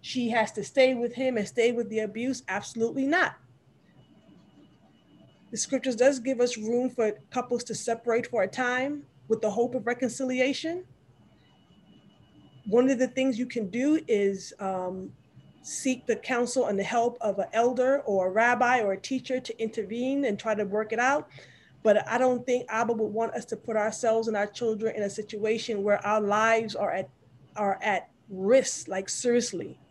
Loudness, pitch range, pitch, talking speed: -27 LUFS, 215-255 Hz, 230 Hz, 180 wpm